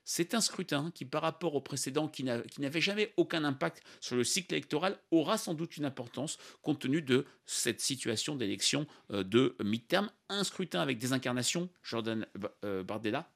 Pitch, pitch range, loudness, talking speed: 150 Hz, 125-180 Hz, -34 LUFS, 185 wpm